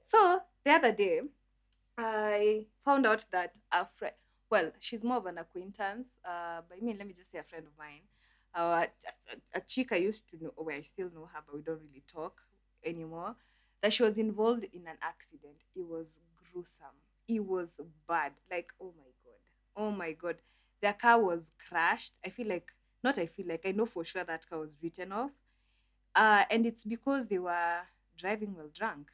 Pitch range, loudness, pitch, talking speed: 165-220 Hz, -33 LUFS, 180 Hz, 200 wpm